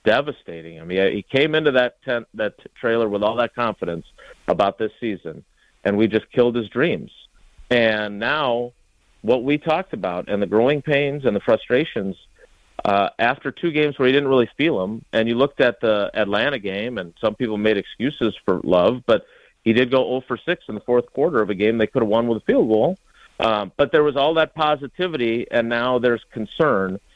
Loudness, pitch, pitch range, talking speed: -20 LUFS, 120 Hz, 105-135 Hz, 205 wpm